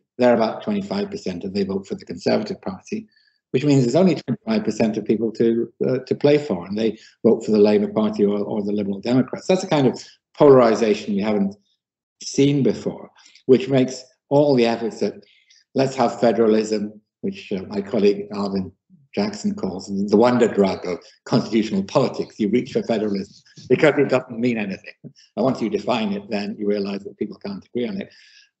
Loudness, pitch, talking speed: -21 LUFS, 130 Hz, 185 wpm